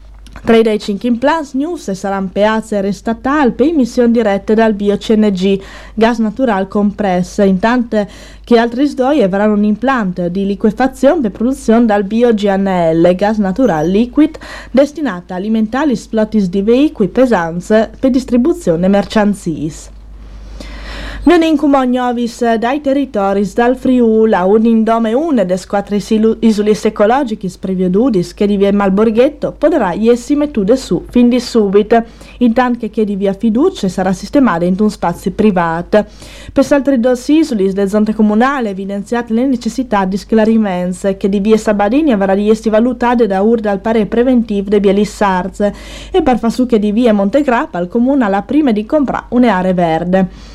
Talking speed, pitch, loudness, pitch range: 150 wpm, 220 Hz, -12 LUFS, 200-245 Hz